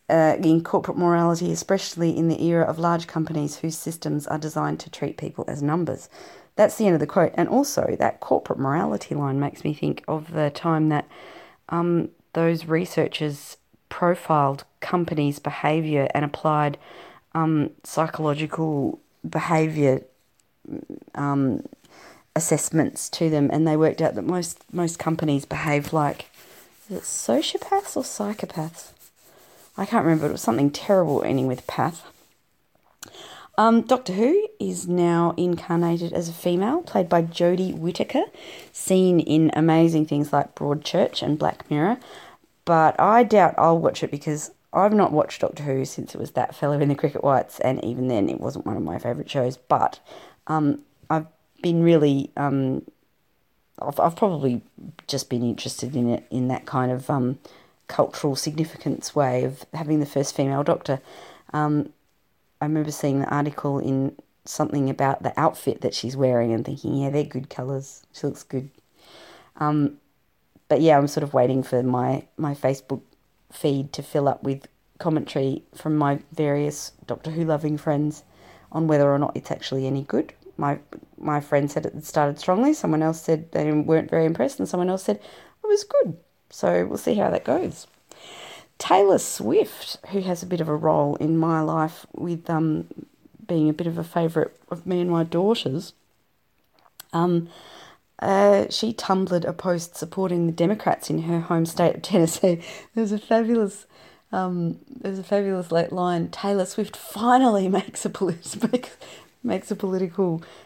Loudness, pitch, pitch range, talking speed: -23 LUFS, 160 Hz, 145-180 Hz, 165 wpm